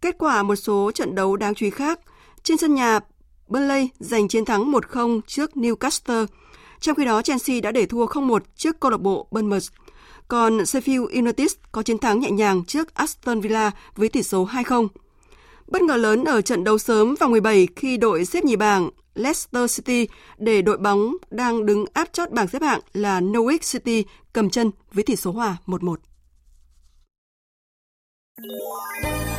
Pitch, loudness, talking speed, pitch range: 225 Hz, -21 LUFS, 170 wpm, 205-270 Hz